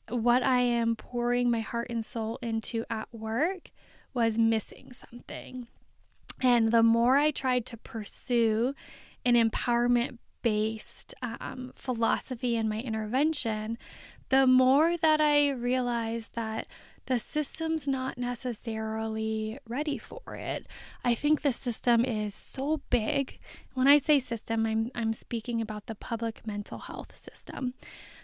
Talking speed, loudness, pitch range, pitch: 130 wpm, -29 LUFS, 225-255 Hz, 240 Hz